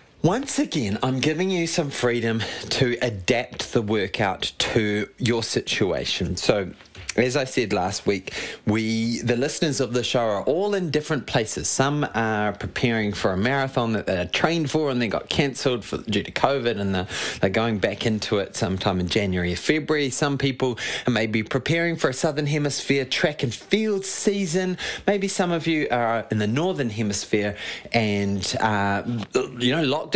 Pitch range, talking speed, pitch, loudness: 110-150 Hz, 175 wpm, 120 Hz, -23 LUFS